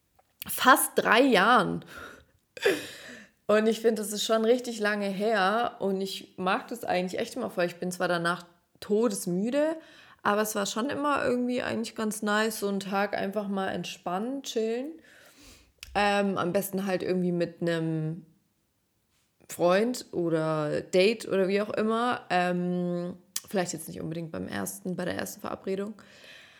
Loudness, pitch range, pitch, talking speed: -28 LUFS, 175-220 Hz, 195 Hz, 150 wpm